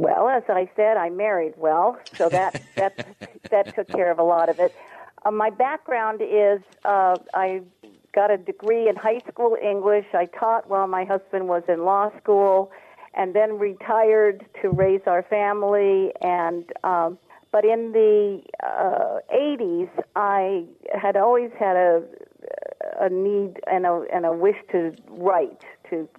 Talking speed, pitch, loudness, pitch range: 160 wpm, 200 Hz, -22 LUFS, 185-215 Hz